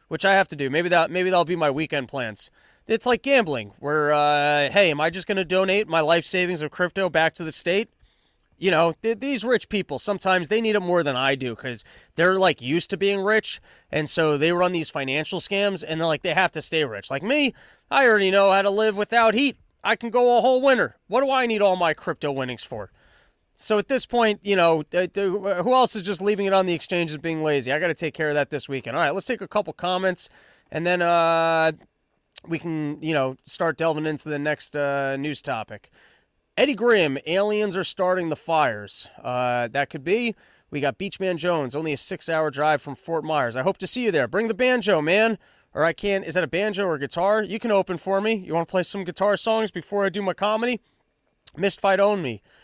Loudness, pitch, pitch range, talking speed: -22 LUFS, 180 Hz, 155-205 Hz, 235 wpm